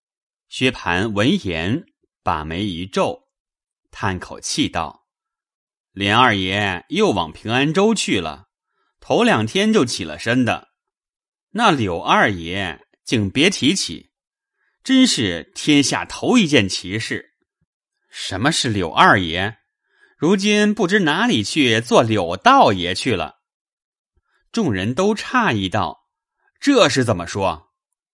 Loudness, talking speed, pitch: -18 LUFS, 165 characters per minute, 155 Hz